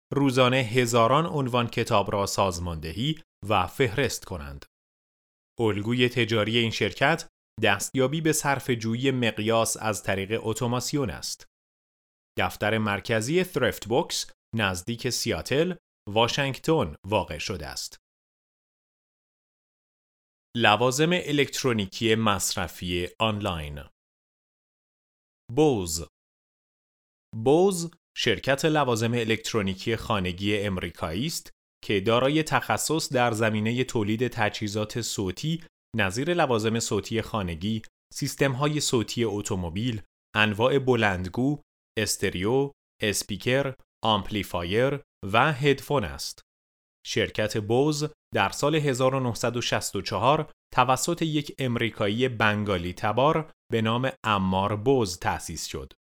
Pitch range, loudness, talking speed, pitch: 100-135 Hz, -26 LUFS, 90 wpm, 115 Hz